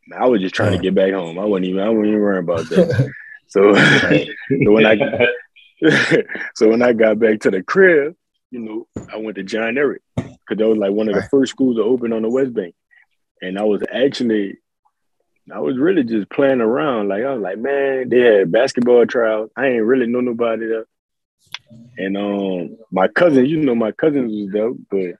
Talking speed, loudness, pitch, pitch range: 210 wpm, -16 LUFS, 110 Hz, 105-130 Hz